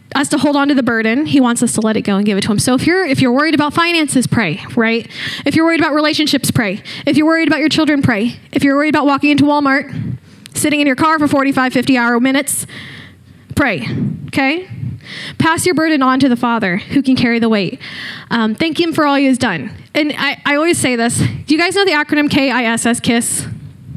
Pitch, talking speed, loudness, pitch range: 280 Hz, 235 wpm, -14 LUFS, 240-300 Hz